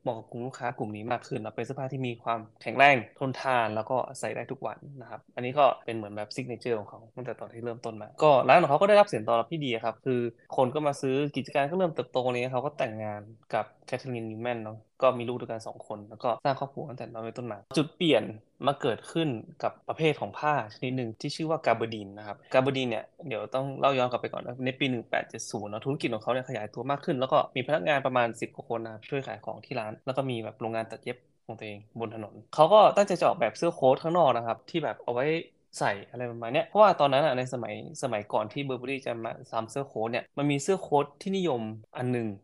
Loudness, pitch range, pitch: -28 LUFS, 115-140 Hz, 125 Hz